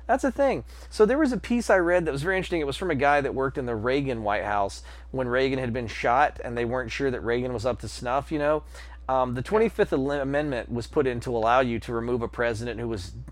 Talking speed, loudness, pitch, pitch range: 265 wpm, -26 LUFS, 130 Hz, 115-150 Hz